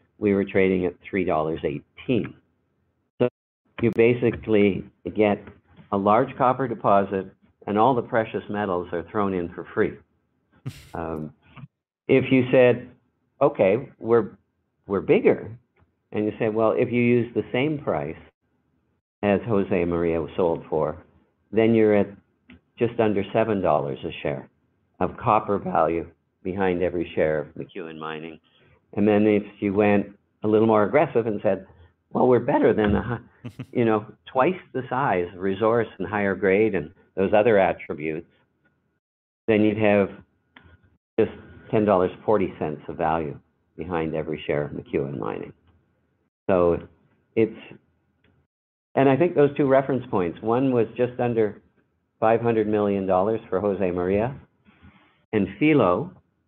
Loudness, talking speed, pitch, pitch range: -23 LUFS, 140 wpm, 105 Hz, 90-115 Hz